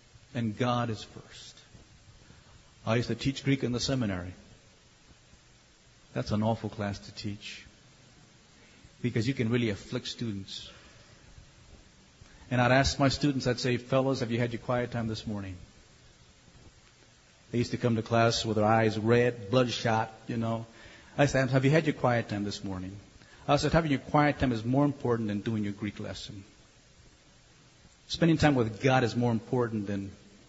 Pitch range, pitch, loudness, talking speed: 105-125 Hz, 115 Hz, -29 LUFS, 170 wpm